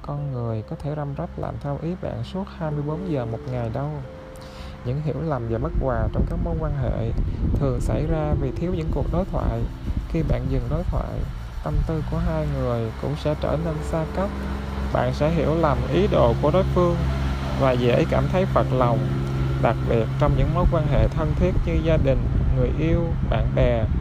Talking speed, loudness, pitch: 205 wpm, -24 LUFS, 125 Hz